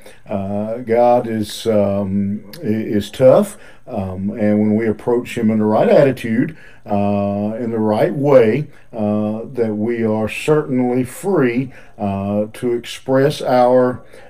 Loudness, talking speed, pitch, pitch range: -17 LUFS, 130 wpm, 110 Hz, 105-120 Hz